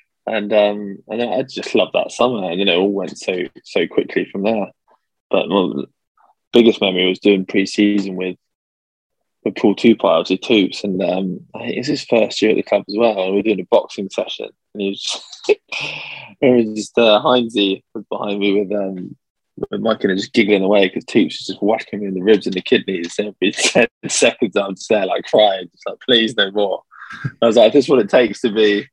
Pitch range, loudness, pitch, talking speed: 95-110 Hz, -17 LUFS, 100 Hz, 235 wpm